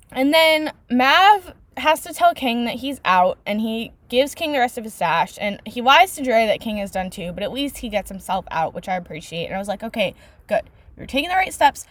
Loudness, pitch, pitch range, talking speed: -20 LUFS, 245 Hz, 195-290 Hz, 250 wpm